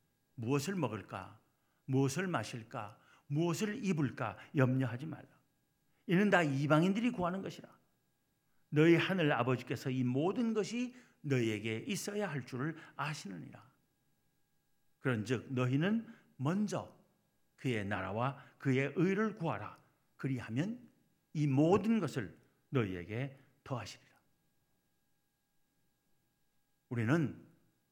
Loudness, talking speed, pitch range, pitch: -35 LUFS, 230 characters per minute, 125-170 Hz, 140 Hz